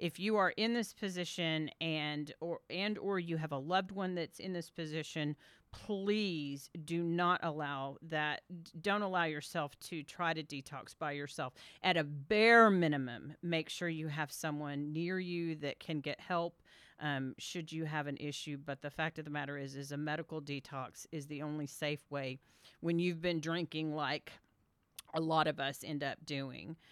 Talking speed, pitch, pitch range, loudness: 185 wpm, 155 Hz, 145-170 Hz, -37 LUFS